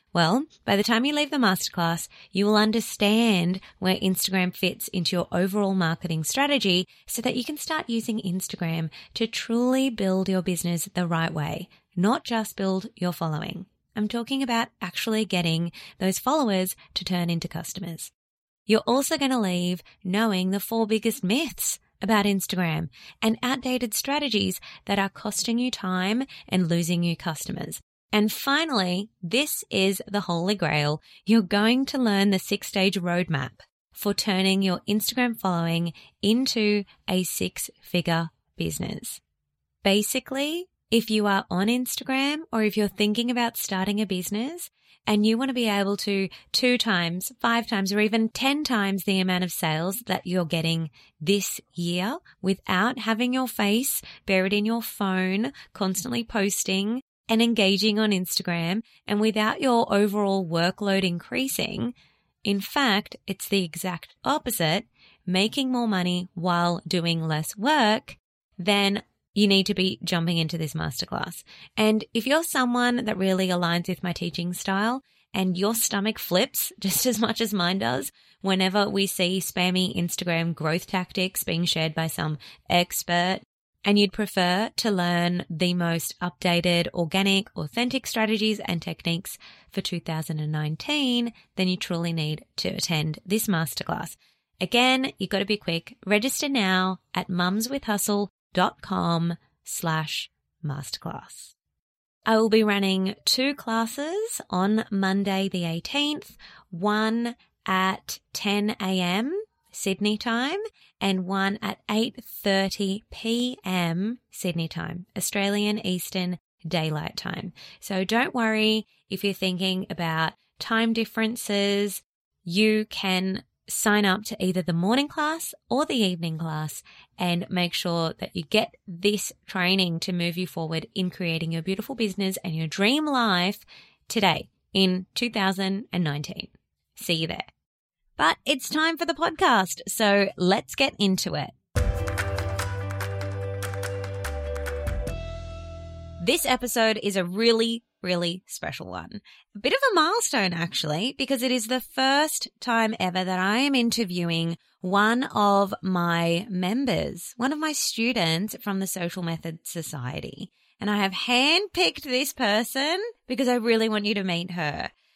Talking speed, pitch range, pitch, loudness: 140 wpm, 175-225 Hz, 195 Hz, -25 LUFS